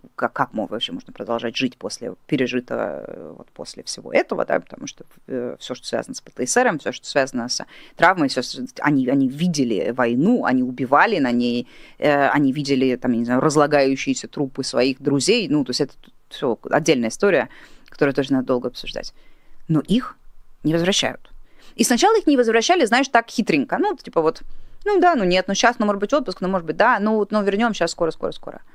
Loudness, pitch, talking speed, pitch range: -20 LUFS, 150 Hz, 200 wpm, 130-215 Hz